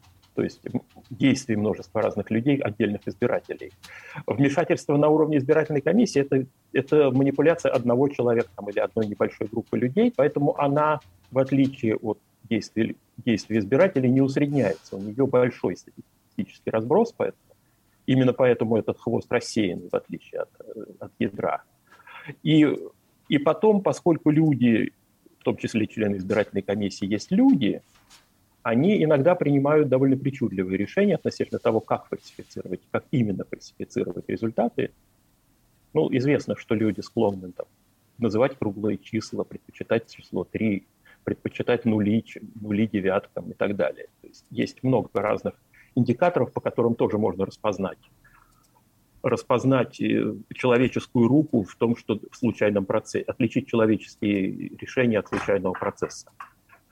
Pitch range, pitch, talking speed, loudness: 105-145 Hz, 120 Hz, 125 wpm, -24 LUFS